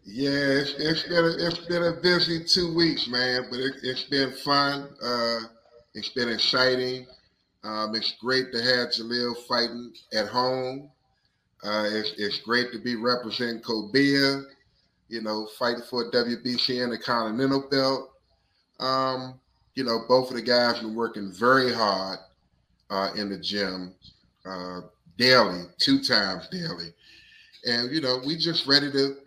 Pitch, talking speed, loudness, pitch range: 125 Hz, 150 wpm, -25 LUFS, 110-135 Hz